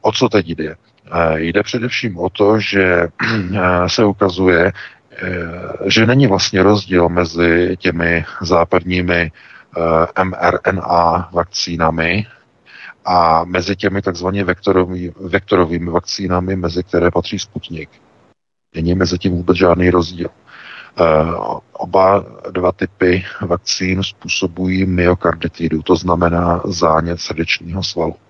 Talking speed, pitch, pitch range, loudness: 100 wpm, 90 Hz, 85-95 Hz, -15 LUFS